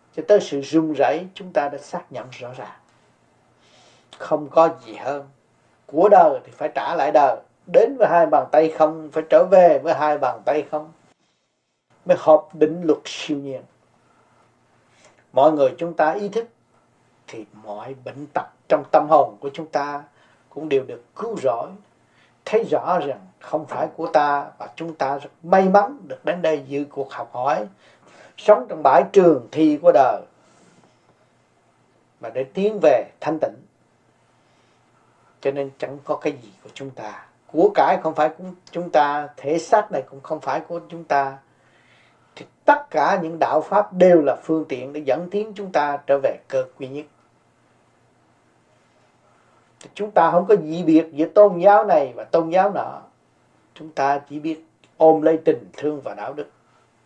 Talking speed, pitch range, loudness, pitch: 175 wpm, 140-170 Hz, -19 LUFS, 155 Hz